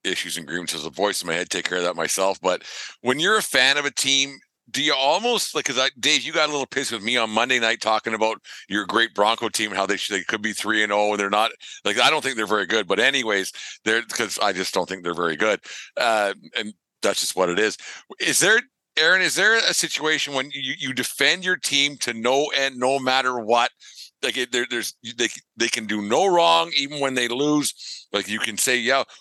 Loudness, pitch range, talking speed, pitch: -21 LUFS, 105-135 Hz, 250 wpm, 120 Hz